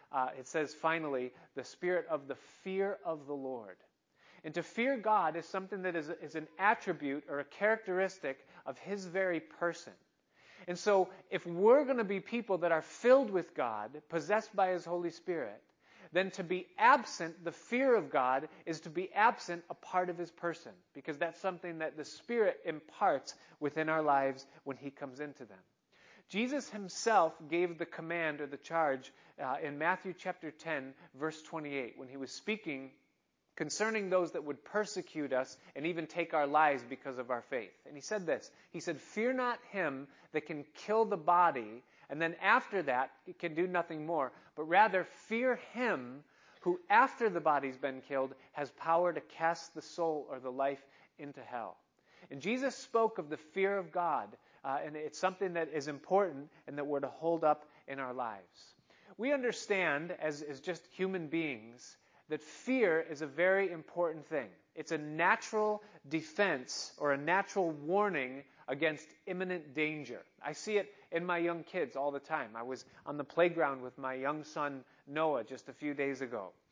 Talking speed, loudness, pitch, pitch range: 180 wpm, -35 LUFS, 165 Hz, 145-185 Hz